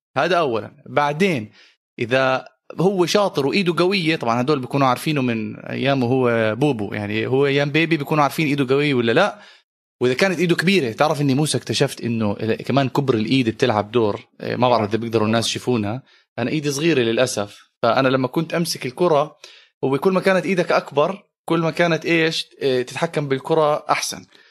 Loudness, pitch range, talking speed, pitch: -20 LUFS, 120-160 Hz, 165 wpm, 140 Hz